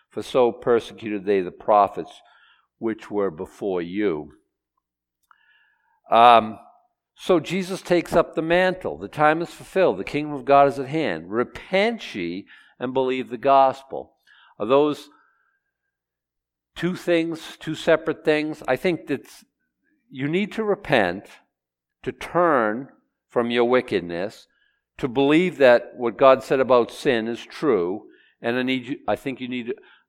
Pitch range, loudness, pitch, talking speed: 120-170 Hz, -22 LUFS, 140 Hz, 145 wpm